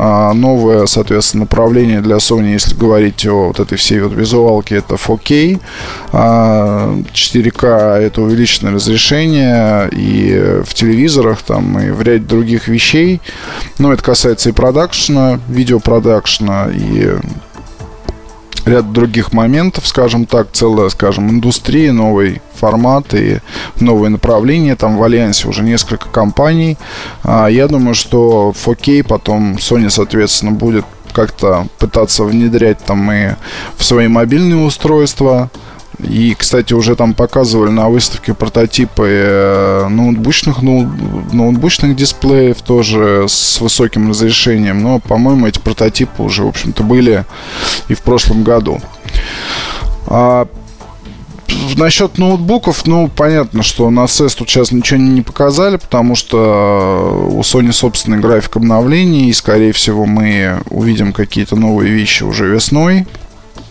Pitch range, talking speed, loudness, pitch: 105-125 Hz, 120 wpm, -10 LUFS, 115 Hz